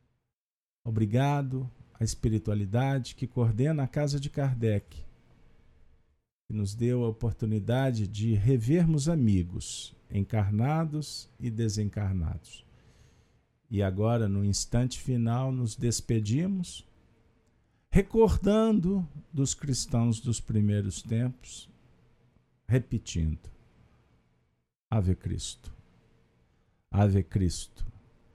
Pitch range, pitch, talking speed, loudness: 105-130 Hz, 115 Hz, 80 wpm, -29 LUFS